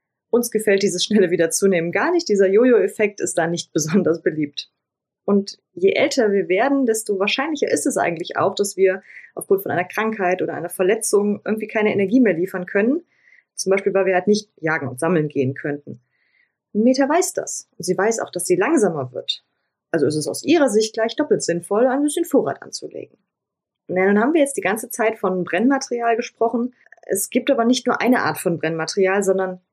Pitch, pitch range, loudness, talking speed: 205 Hz, 185-245 Hz, -20 LUFS, 195 wpm